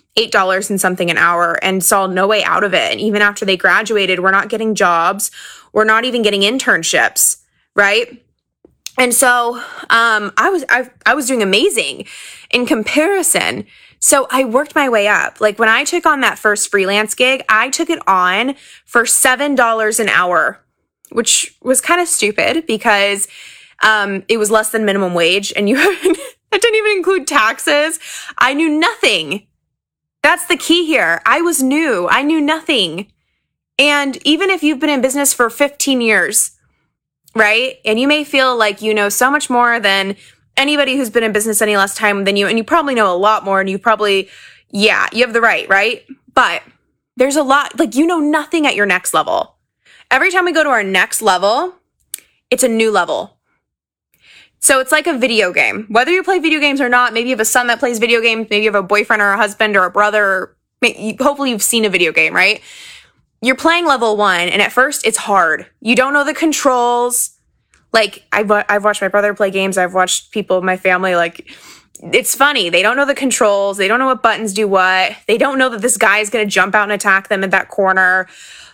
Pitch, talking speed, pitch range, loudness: 230 Hz, 205 wpm, 205-285 Hz, -13 LUFS